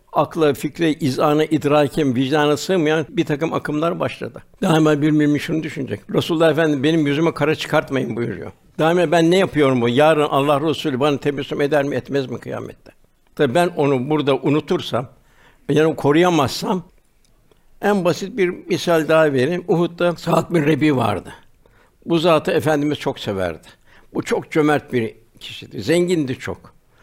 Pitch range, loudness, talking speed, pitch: 140-165 Hz, -18 LUFS, 155 wpm, 150 Hz